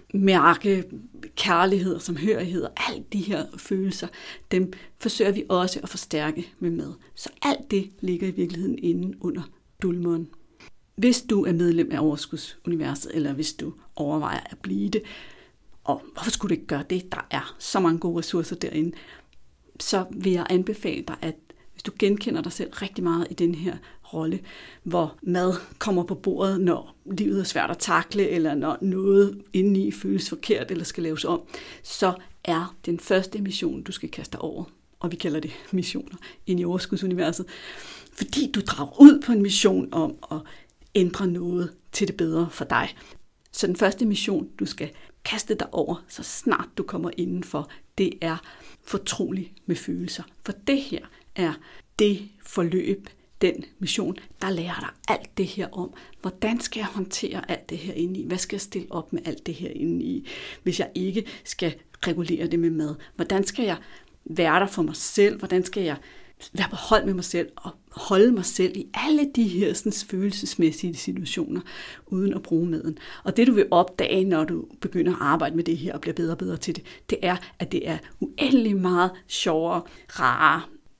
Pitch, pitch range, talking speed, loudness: 185 Hz, 170-205 Hz, 185 wpm, -25 LUFS